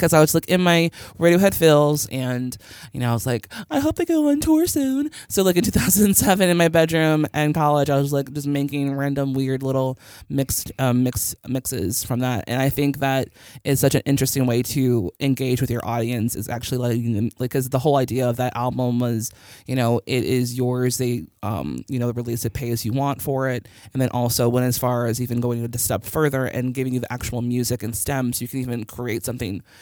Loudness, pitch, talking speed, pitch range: -21 LUFS, 130 Hz, 230 wpm, 120-140 Hz